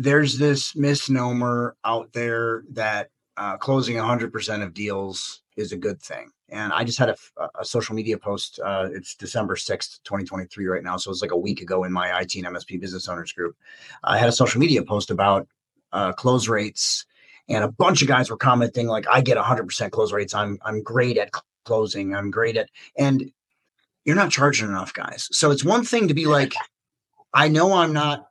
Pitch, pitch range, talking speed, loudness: 115 Hz, 100-140 Hz, 195 wpm, -22 LUFS